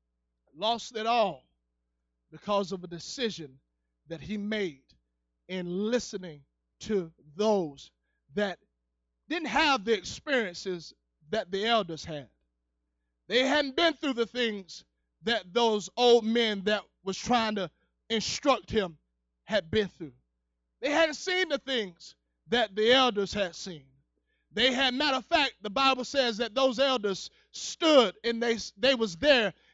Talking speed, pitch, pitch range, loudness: 140 wpm, 205 Hz, 145-240 Hz, -28 LUFS